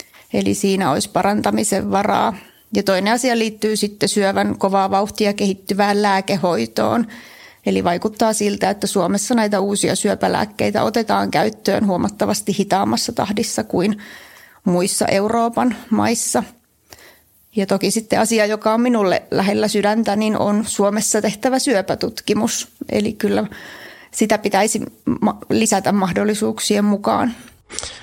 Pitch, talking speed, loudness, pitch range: 205 Hz, 115 wpm, -18 LUFS, 195-220 Hz